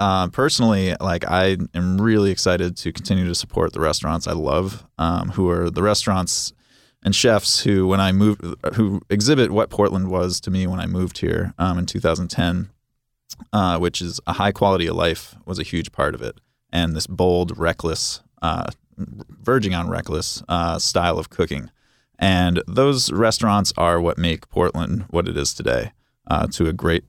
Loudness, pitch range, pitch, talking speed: -20 LUFS, 85-100 Hz, 90 Hz, 180 wpm